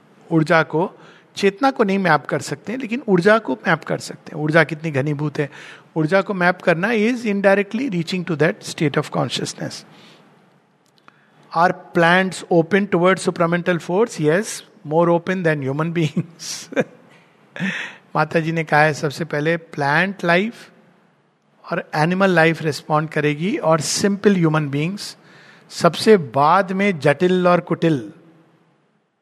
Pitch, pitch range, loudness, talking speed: 170 Hz, 155-195 Hz, -19 LUFS, 140 wpm